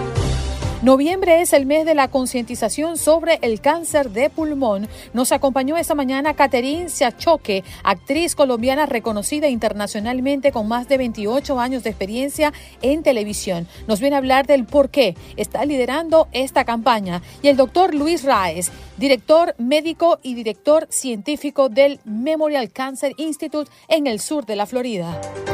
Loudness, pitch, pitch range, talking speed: -19 LUFS, 275 Hz, 235-300 Hz, 145 wpm